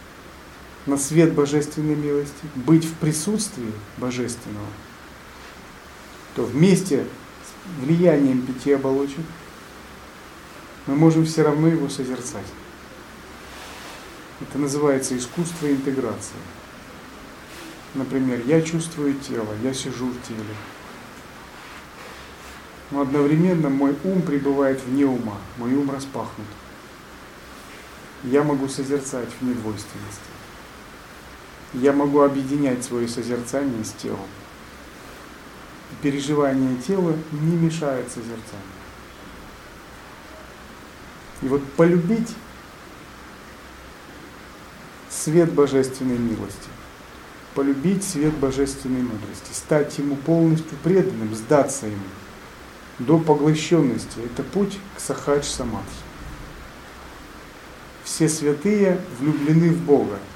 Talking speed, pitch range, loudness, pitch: 85 wpm, 120-155 Hz, -22 LUFS, 140 Hz